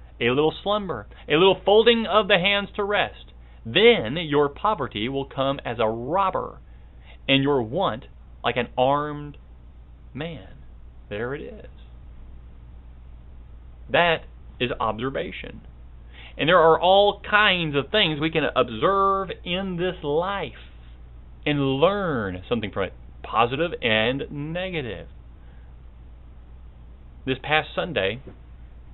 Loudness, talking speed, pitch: -22 LUFS, 115 wpm, 110 Hz